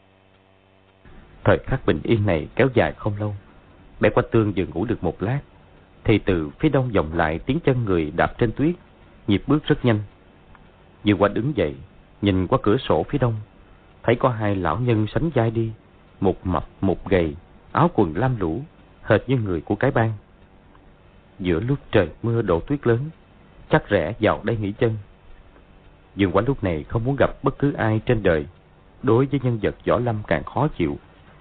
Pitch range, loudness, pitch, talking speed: 95-115 Hz, -22 LUFS, 100 Hz, 190 wpm